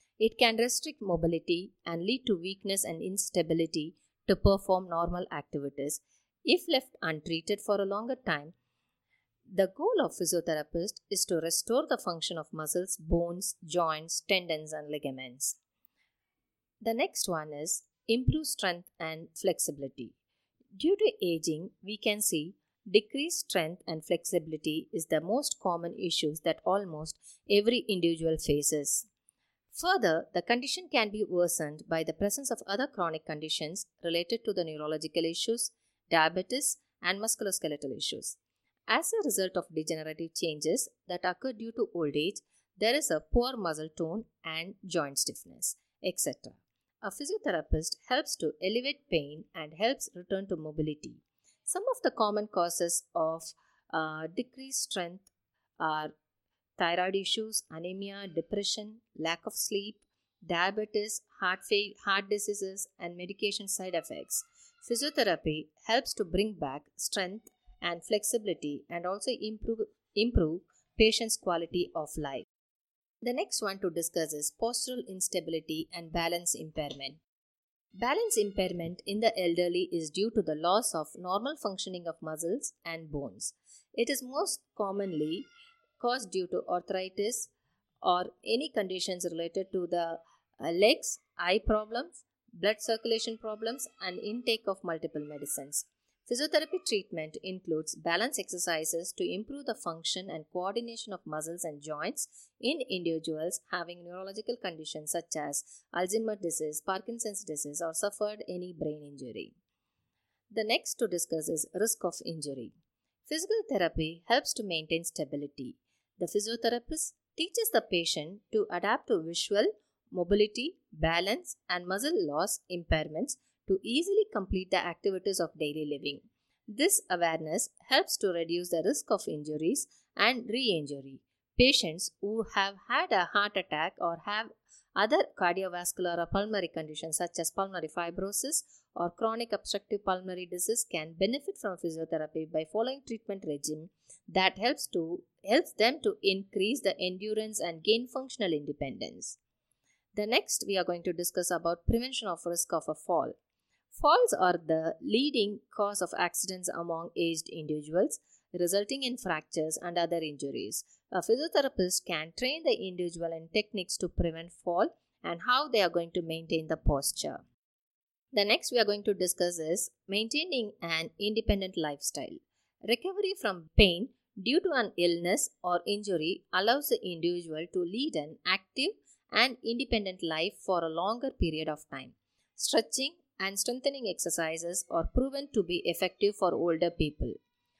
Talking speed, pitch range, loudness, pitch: 140 wpm, 165-220 Hz, -32 LUFS, 185 Hz